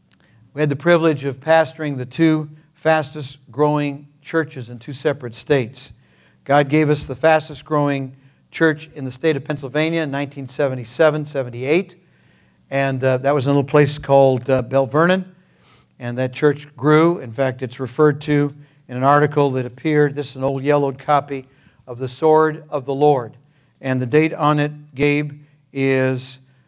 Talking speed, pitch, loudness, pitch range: 160 wpm, 145 Hz, -19 LUFS, 130-150 Hz